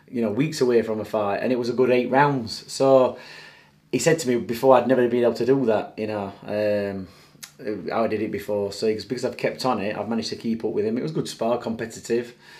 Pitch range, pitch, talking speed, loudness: 110-125 Hz, 115 Hz, 255 wpm, -23 LUFS